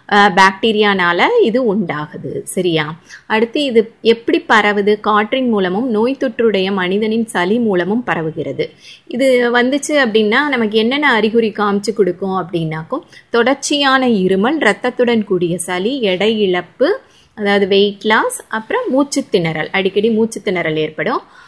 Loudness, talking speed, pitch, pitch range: -15 LUFS, 115 wpm, 220 Hz, 195-250 Hz